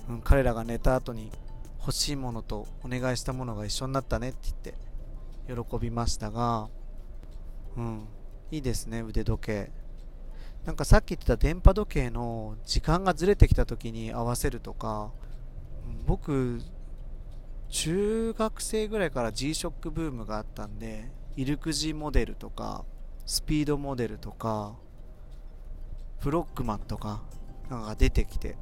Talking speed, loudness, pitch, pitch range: 285 characters per minute, -30 LUFS, 120 Hz, 110-140 Hz